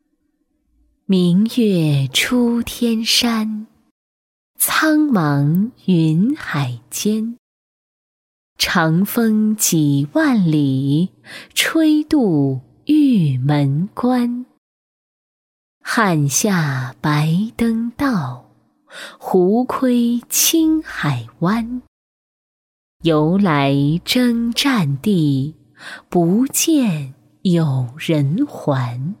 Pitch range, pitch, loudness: 150-245 Hz, 200 Hz, -17 LUFS